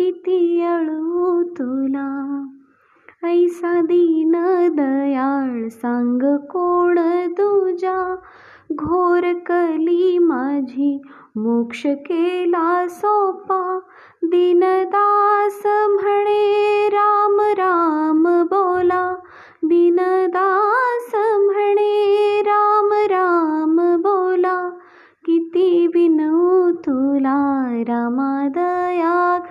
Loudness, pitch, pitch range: -17 LUFS, 350 Hz, 315-380 Hz